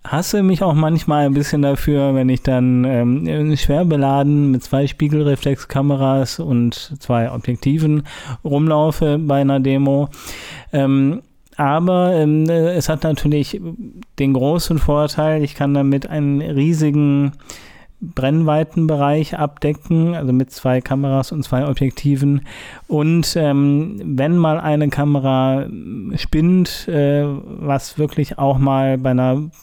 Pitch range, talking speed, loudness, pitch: 135-155 Hz, 120 wpm, -17 LUFS, 145 Hz